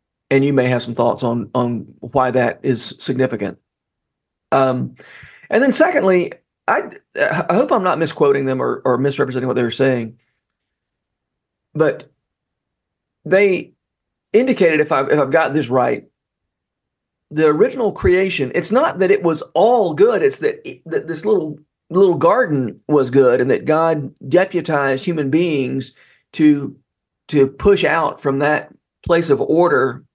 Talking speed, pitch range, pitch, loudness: 145 wpm, 130-175 Hz, 145 Hz, -17 LUFS